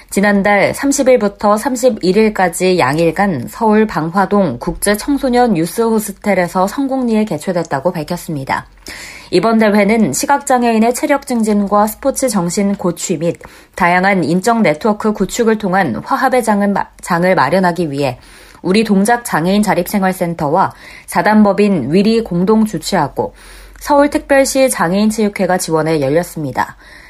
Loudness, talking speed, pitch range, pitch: -14 LUFS, 310 characters per minute, 175-225 Hz, 200 Hz